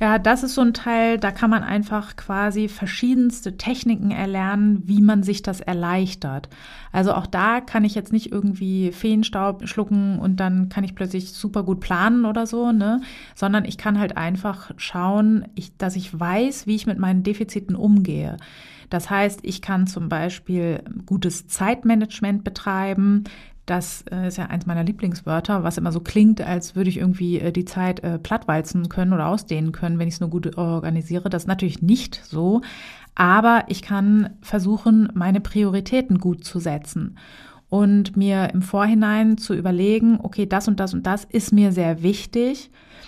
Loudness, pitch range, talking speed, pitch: -21 LUFS, 180-215 Hz, 170 wpm, 195 Hz